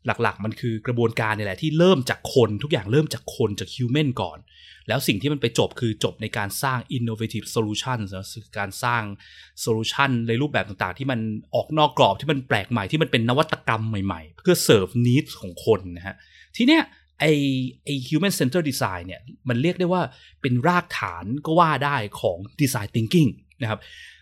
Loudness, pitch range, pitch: -23 LUFS, 110-145 Hz, 120 Hz